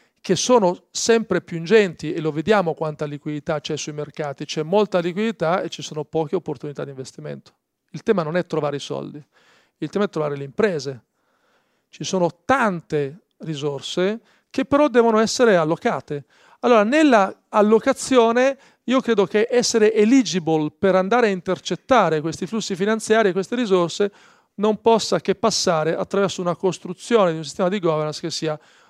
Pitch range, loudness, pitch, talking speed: 155-220 Hz, -20 LUFS, 180 Hz, 160 wpm